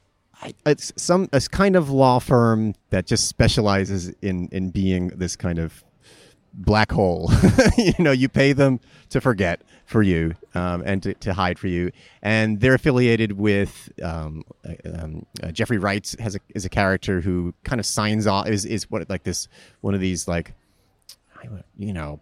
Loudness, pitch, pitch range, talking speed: -21 LUFS, 100 Hz, 90-115 Hz, 175 wpm